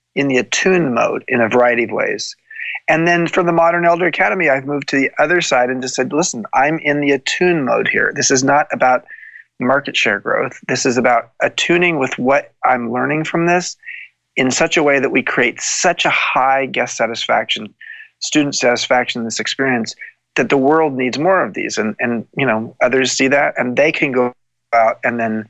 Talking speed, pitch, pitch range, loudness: 205 wpm, 140 Hz, 125-175 Hz, -15 LUFS